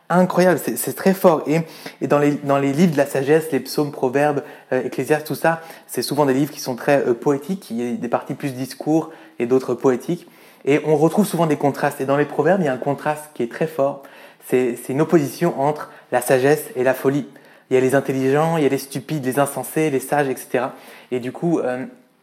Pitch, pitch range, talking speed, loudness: 145 Hz, 130-155 Hz, 245 wpm, -20 LUFS